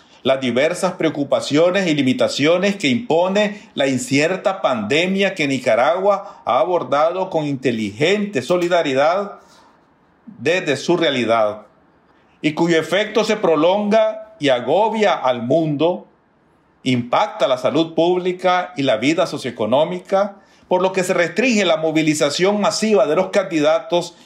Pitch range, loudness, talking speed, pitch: 145-200 Hz, -18 LUFS, 120 wpm, 175 Hz